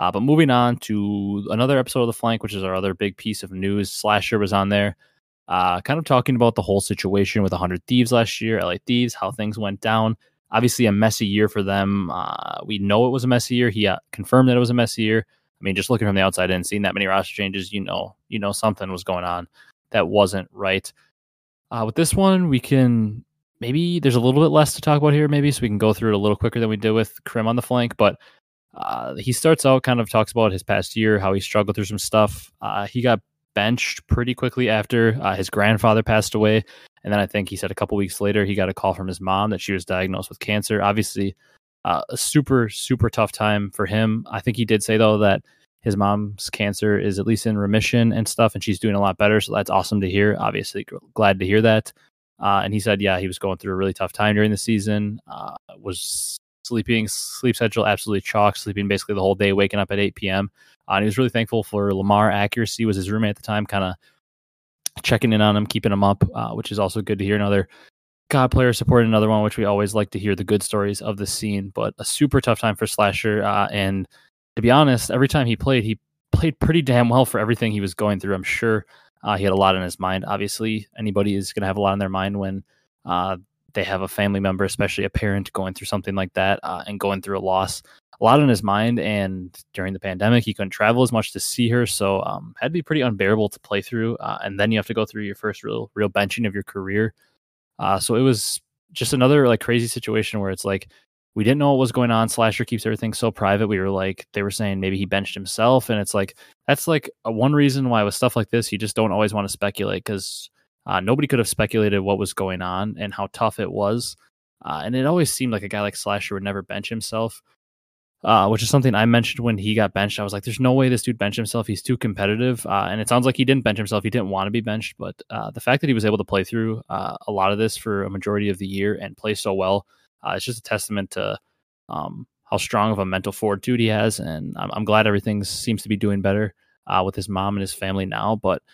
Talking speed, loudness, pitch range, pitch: 255 wpm, -21 LUFS, 100-115 Hz, 105 Hz